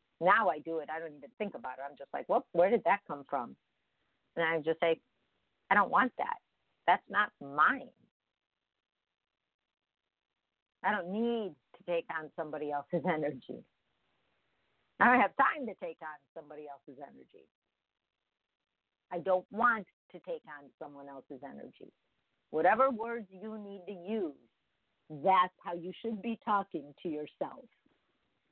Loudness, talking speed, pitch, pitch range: -32 LUFS, 150 wpm, 165 Hz, 150-200 Hz